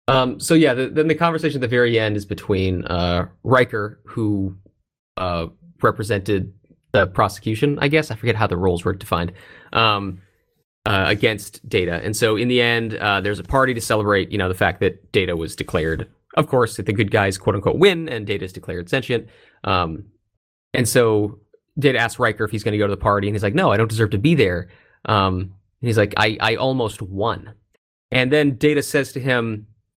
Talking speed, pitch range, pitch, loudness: 210 wpm, 100-125 Hz, 110 Hz, -20 LUFS